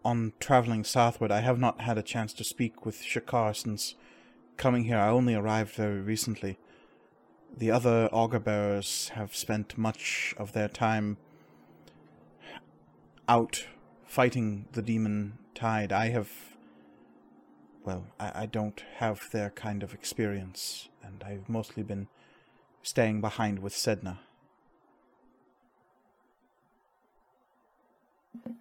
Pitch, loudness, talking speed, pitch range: 110 Hz, -30 LUFS, 115 wpm, 100-115 Hz